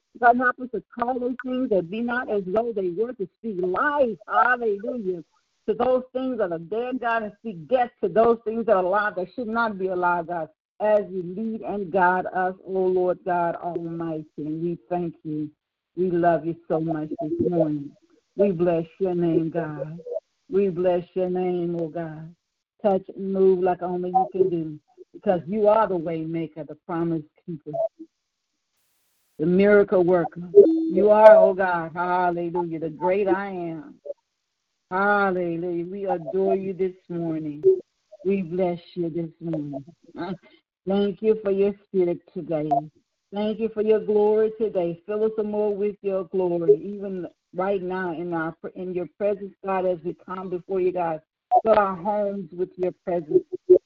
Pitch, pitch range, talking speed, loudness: 185 Hz, 170-210 Hz, 165 wpm, -24 LUFS